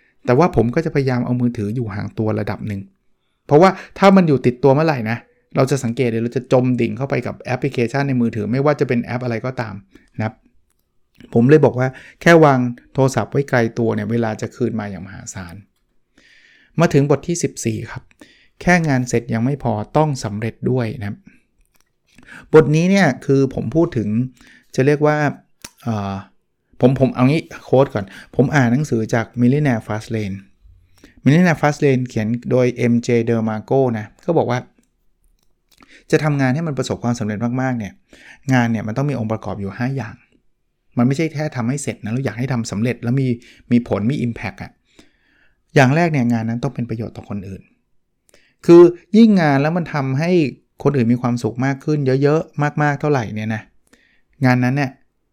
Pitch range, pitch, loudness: 115-140 Hz, 125 Hz, -18 LUFS